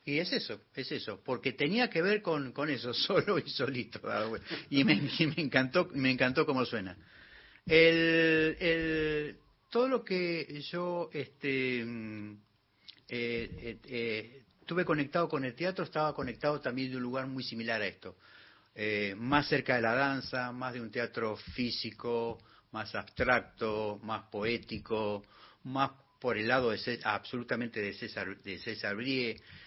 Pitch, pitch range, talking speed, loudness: 130 Hz, 115-155 Hz, 155 wpm, -32 LUFS